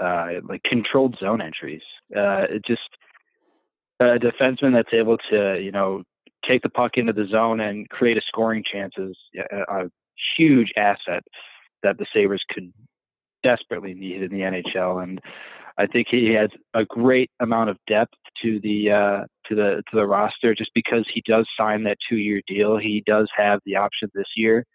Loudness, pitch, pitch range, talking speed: -21 LUFS, 105 Hz, 100-115 Hz, 180 wpm